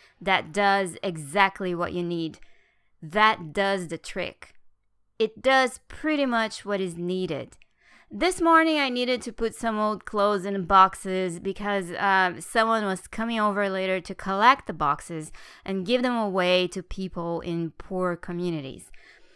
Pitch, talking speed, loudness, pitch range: 195 Hz, 150 wpm, -25 LUFS, 175-215 Hz